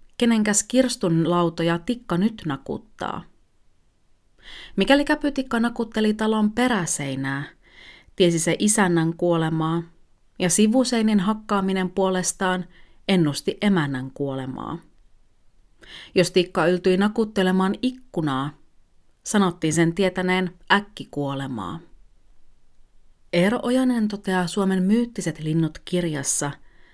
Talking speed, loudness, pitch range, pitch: 85 wpm, -22 LUFS, 165-215 Hz, 185 Hz